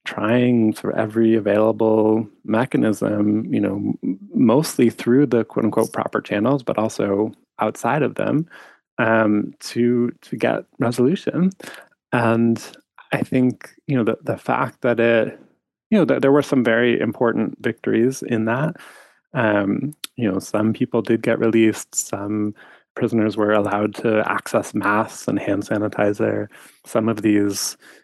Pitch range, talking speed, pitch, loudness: 105-120 Hz, 140 wpm, 115 Hz, -20 LUFS